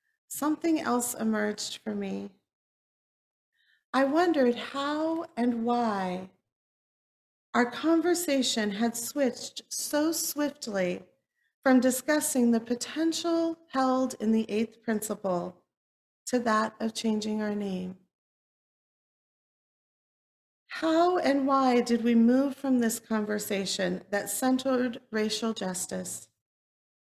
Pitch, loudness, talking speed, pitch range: 240 Hz, -28 LUFS, 95 wpm, 215-275 Hz